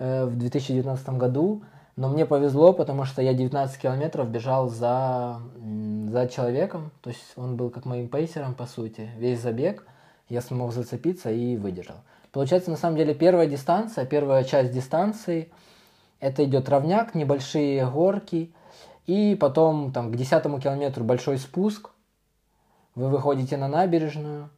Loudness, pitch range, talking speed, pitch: -25 LUFS, 125-160 Hz, 140 wpm, 135 Hz